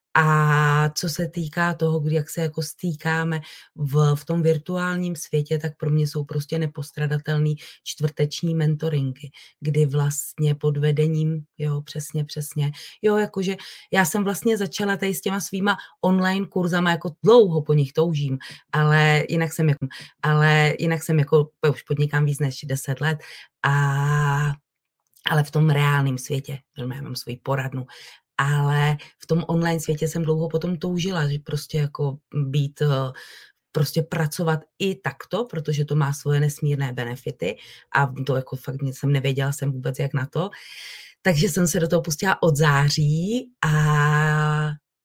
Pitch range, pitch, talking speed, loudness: 145-165 Hz, 150 Hz, 150 wpm, -23 LUFS